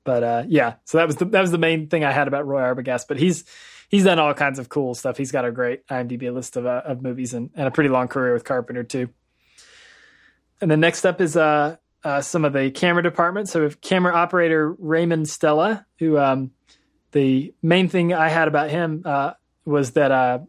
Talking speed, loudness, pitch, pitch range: 225 wpm, -20 LUFS, 145 Hz, 130-165 Hz